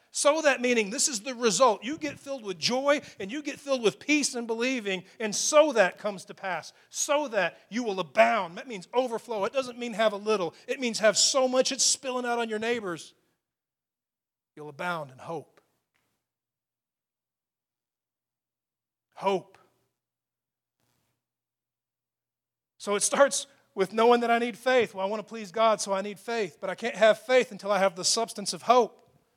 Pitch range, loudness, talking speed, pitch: 195-255 Hz, -26 LUFS, 180 wpm, 225 Hz